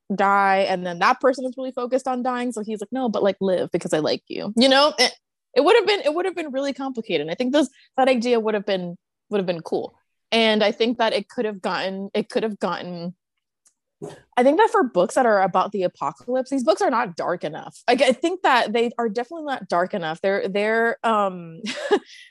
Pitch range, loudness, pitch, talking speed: 195-260 Hz, -21 LUFS, 230 Hz, 235 wpm